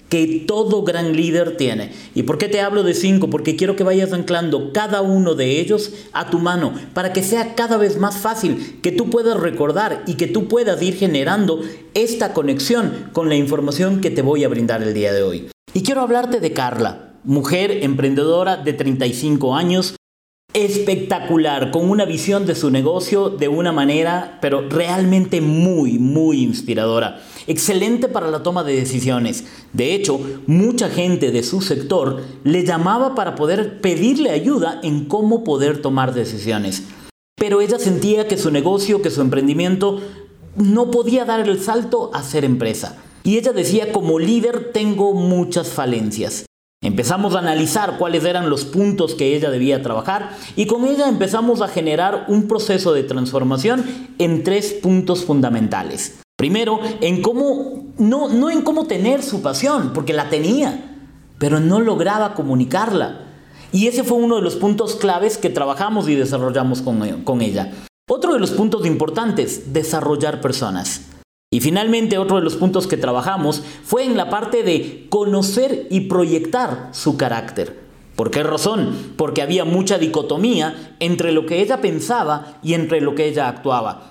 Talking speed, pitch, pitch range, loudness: 165 wpm, 180 Hz, 145-210 Hz, -18 LUFS